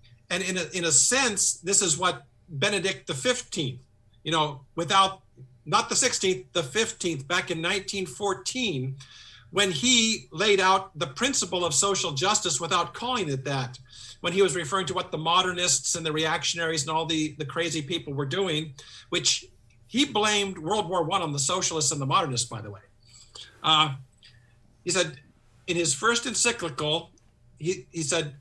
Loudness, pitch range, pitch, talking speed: -25 LUFS, 135-190 Hz, 170 Hz, 170 wpm